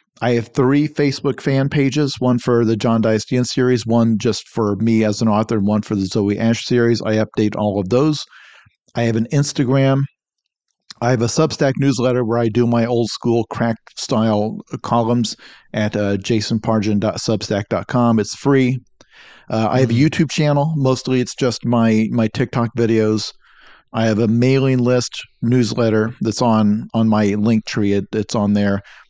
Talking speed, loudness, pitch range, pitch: 170 wpm, -17 LUFS, 110-125 Hz, 115 Hz